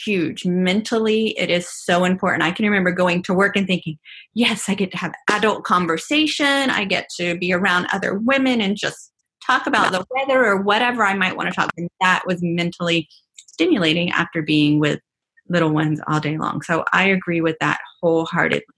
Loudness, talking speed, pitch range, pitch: -19 LUFS, 190 wpm, 170-205 Hz, 180 Hz